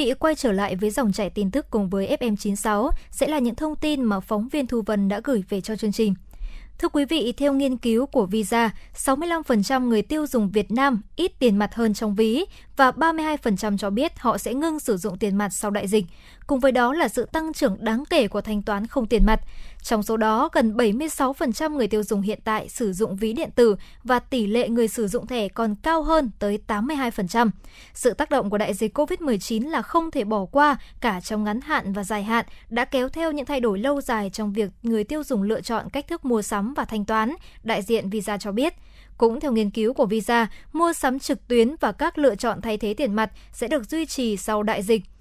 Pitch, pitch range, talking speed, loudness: 230 Hz, 215-275 Hz, 230 wpm, -23 LUFS